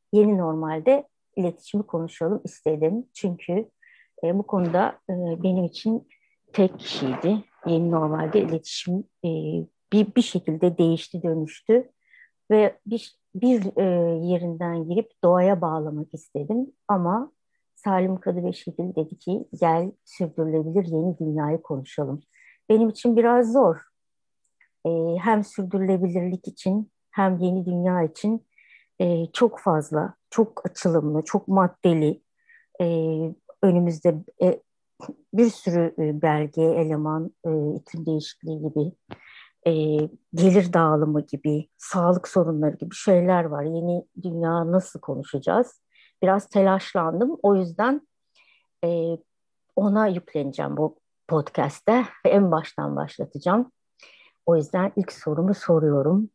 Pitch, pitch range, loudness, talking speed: 180 Hz, 160-205 Hz, -24 LUFS, 105 wpm